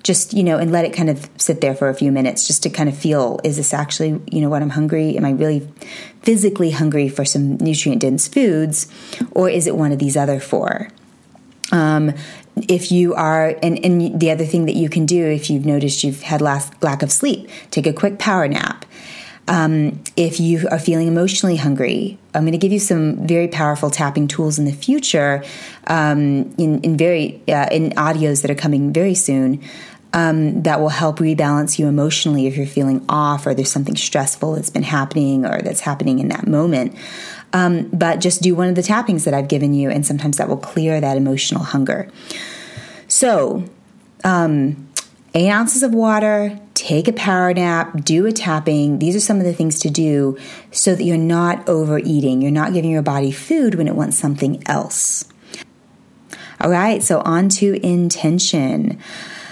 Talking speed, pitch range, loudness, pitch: 195 wpm, 145-180 Hz, -17 LUFS, 160 Hz